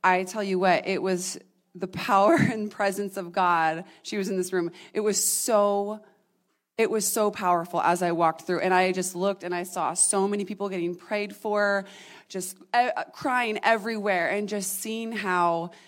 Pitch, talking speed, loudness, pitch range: 195 Hz, 180 wpm, -25 LUFS, 180-210 Hz